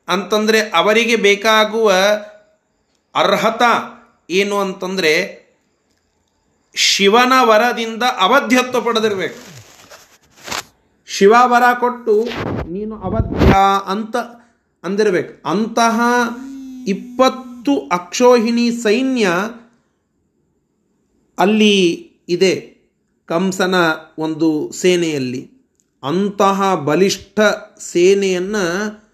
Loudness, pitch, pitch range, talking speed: -15 LUFS, 210 Hz, 185-235 Hz, 60 wpm